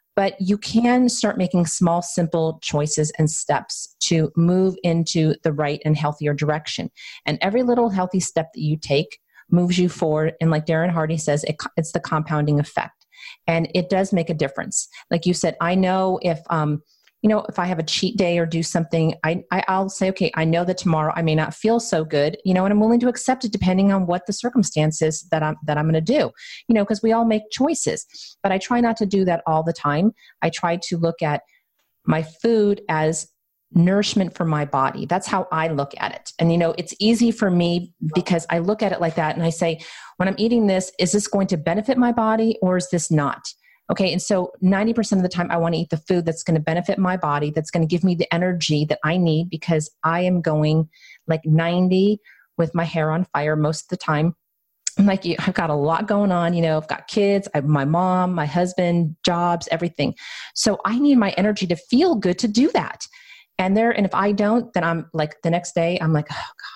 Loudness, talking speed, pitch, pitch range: -21 LUFS, 230 wpm, 175 Hz, 160-195 Hz